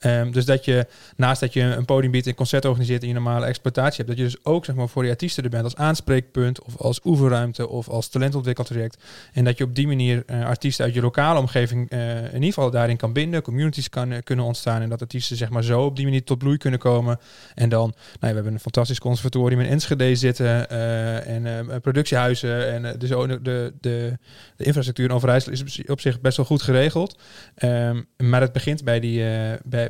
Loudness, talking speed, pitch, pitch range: -22 LUFS, 235 wpm, 125 Hz, 120-135 Hz